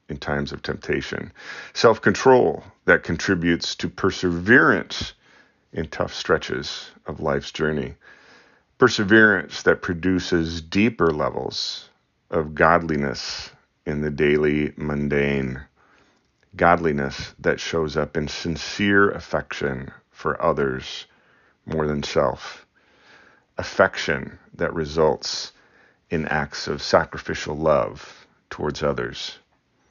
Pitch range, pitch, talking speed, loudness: 70-90 Hz, 75 Hz, 100 wpm, -22 LUFS